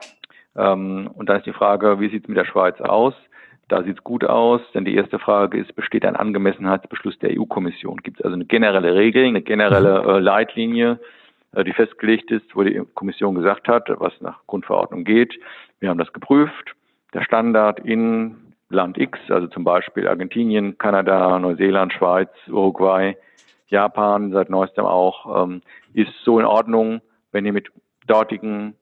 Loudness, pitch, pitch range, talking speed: -19 LUFS, 105 Hz, 95-115 Hz, 160 wpm